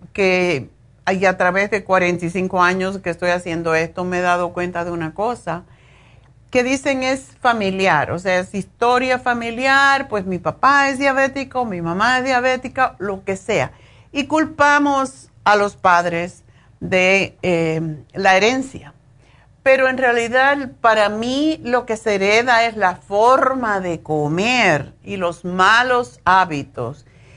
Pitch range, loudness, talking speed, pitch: 170-250 Hz, -17 LUFS, 145 wpm, 190 Hz